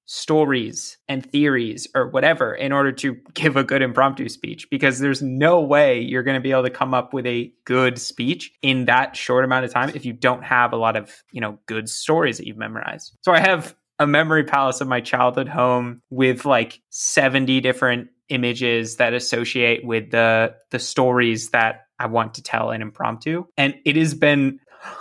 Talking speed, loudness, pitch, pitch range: 195 wpm, -20 LUFS, 130 Hz, 120-135 Hz